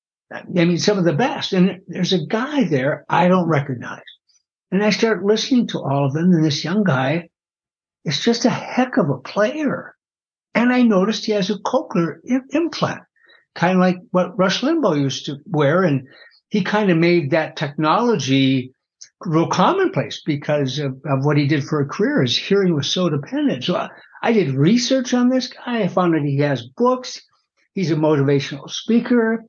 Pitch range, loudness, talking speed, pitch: 155-225 Hz, -19 LUFS, 185 wpm, 185 Hz